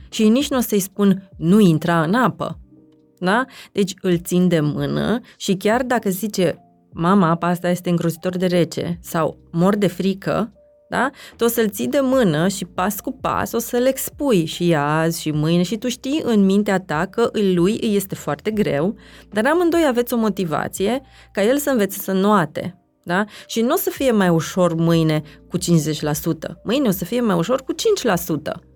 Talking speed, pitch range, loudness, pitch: 190 wpm, 170-230 Hz, -19 LUFS, 190 Hz